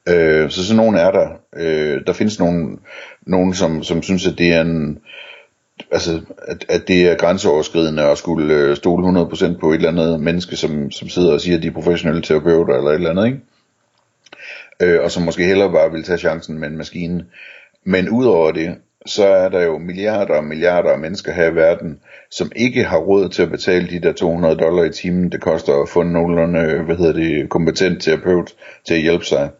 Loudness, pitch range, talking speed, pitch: -16 LUFS, 80-90 Hz, 205 wpm, 85 Hz